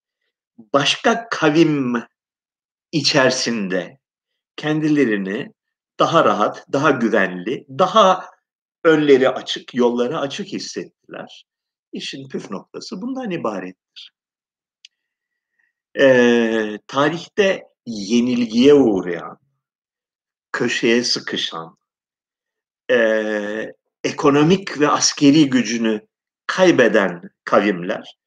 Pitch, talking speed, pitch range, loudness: 145 Hz, 70 wpm, 120-200 Hz, -17 LUFS